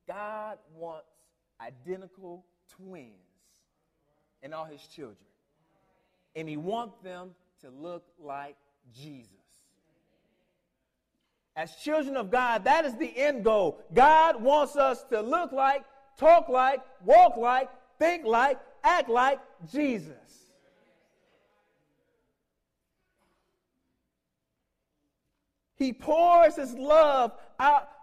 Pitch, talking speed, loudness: 230 Hz, 95 wpm, -24 LUFS